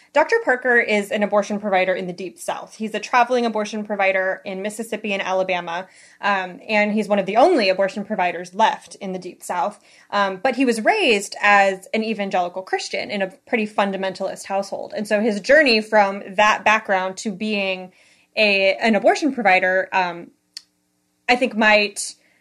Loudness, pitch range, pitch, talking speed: -19 LUFS, 190-220 Hz, 205 Hz, 170 wpm